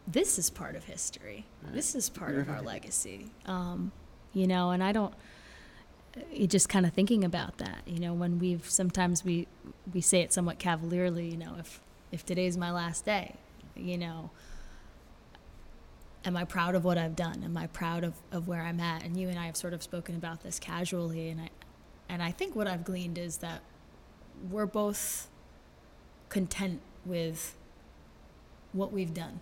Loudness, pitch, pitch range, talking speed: -33 LUFS, 175 Hz, 170-185 Hz, 175 wpm